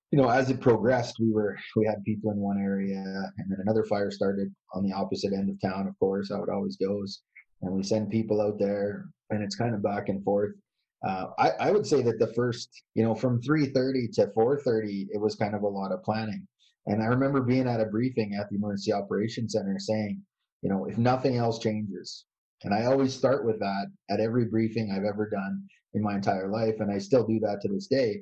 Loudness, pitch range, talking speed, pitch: -28 LUFS, 100-110 Hz, 230 wpm, 105 Hz